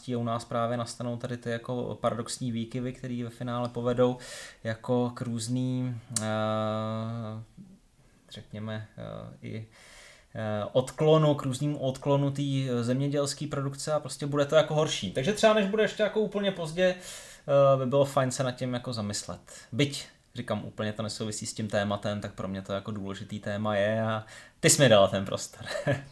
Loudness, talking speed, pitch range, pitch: -29 LUFS, 155 wpm, 110-140 Hz, 125 Hz